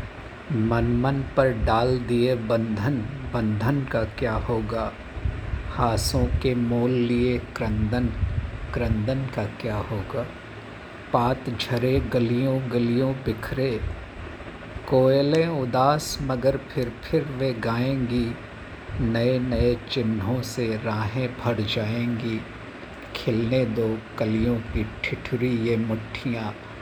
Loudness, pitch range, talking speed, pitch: -25 LUFS, 110-125 Hz, 100 wpm, 120 Hz